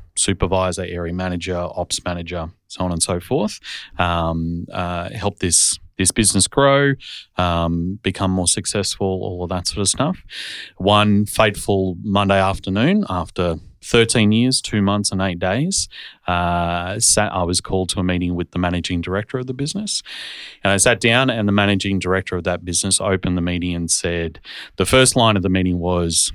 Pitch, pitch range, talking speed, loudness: 95 Hz, 90-105 Hz, 175 wpm, -18 LUFS